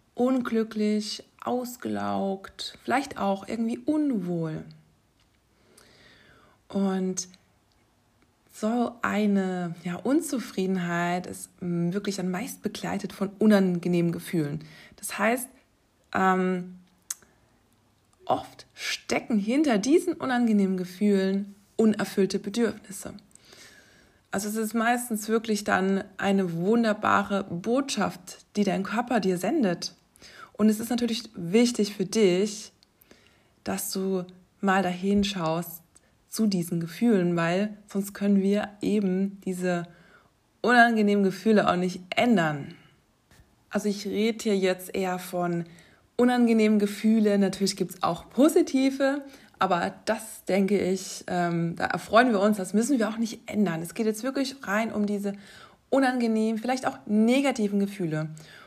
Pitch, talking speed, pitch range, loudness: 200 Hz, 110 wpm, 185-225 Hz, -26 LUFS